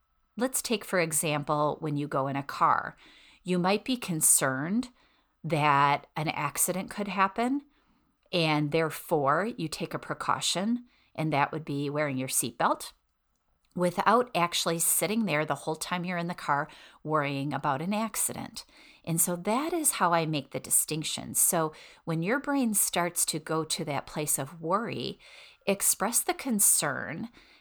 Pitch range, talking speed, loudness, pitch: 150-205 Hz, 155 wpm, -28 LUFS, 165 Hz